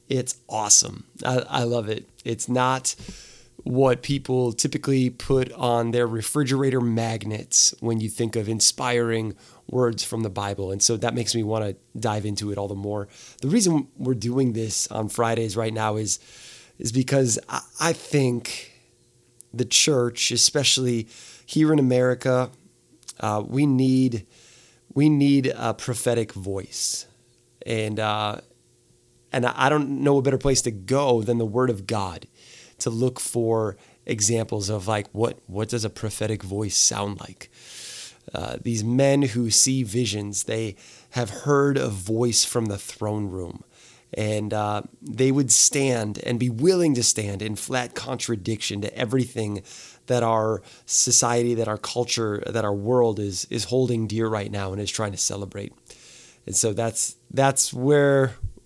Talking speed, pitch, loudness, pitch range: 155 wpm, 115 Hz, -23 LUFS, 105-125 Hz